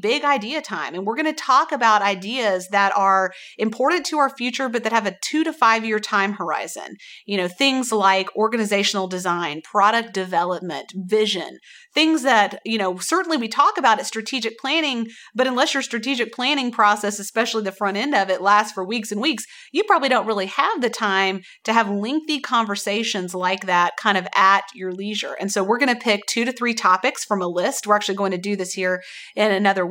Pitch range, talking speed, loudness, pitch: 195-255 Hz, 205 wpm, -20 LUFS, 215 Hz